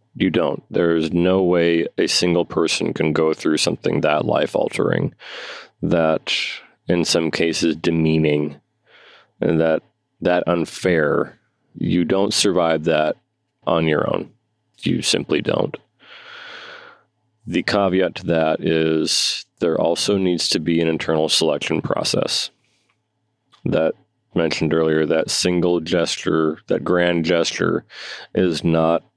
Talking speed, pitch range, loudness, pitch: 120 wpm, 80-90 Hz, -19 LUFS, 85 Hz